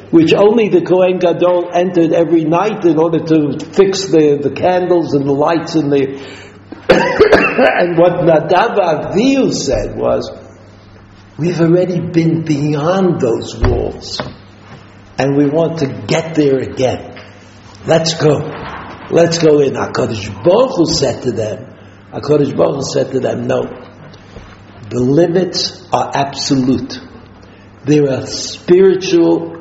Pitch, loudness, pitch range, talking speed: 150 Hz, -13 LUFS, 125-170 Hz, 125 wpm